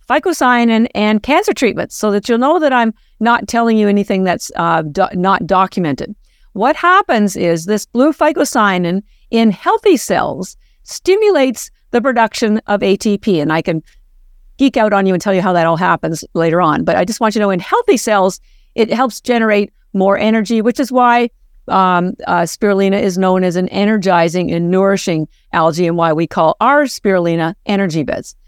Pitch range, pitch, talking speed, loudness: 180-235 Hz, 205 Hz, 180 wpm, -14 LUFS